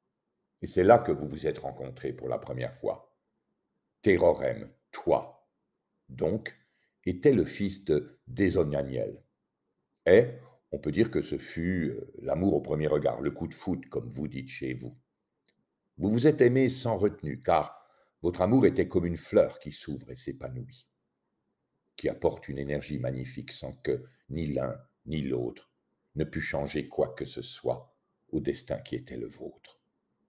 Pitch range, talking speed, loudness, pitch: 70-105 Hz, 160 wpm, -30 LUFS, 80 Hz